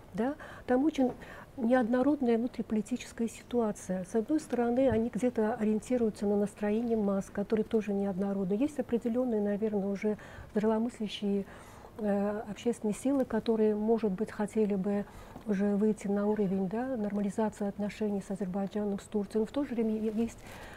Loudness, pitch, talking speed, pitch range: -32 LUFS, 215 Hz, 135 wpm, 205-235 Hz